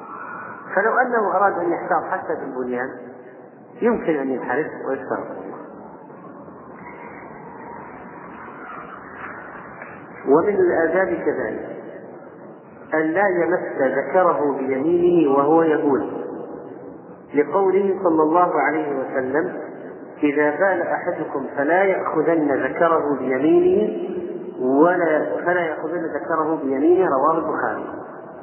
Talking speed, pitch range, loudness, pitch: 85 wpm, 145-195 Hz, -20 LUFS, 165 Hz